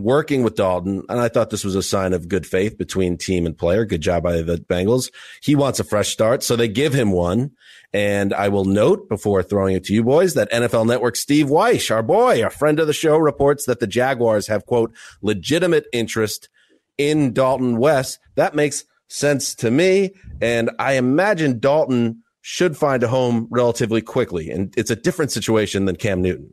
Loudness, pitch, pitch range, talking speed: -19 LUFS, 115 Hz, 100-140 Hz, 200 wpm